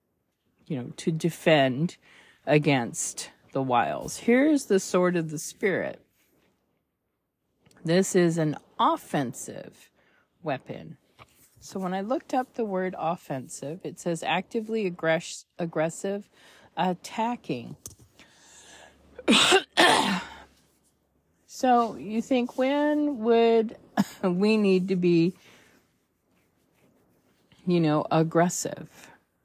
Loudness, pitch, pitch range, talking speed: -26 LUFS, 180 Hz, 160-225 Hz, 90 wpm